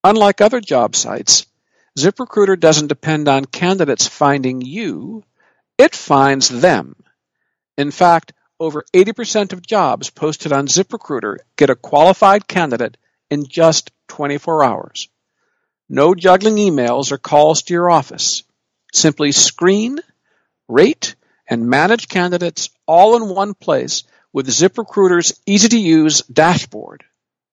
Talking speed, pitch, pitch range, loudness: 120 wpm, 175 Hz, 150-205 Hz, -14 LUFS